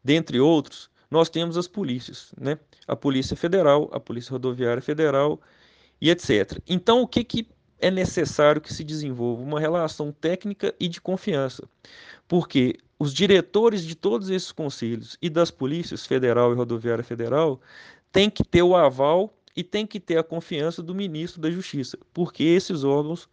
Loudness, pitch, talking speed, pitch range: -24 LUFS, 160 Hz, 160 wpm, 140-180 Hz